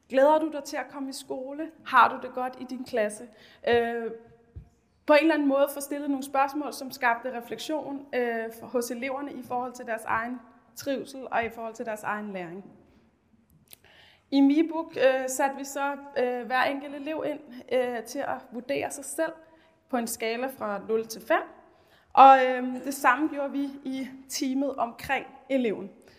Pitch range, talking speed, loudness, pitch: 240-280 Hz, 165 wpm, -27 LUFS, 265 Hz